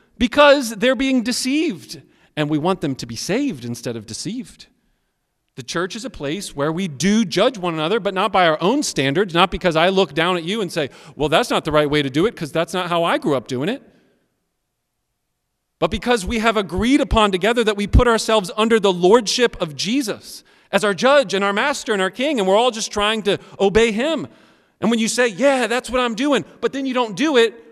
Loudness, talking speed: -18 LUFS, 230 wpm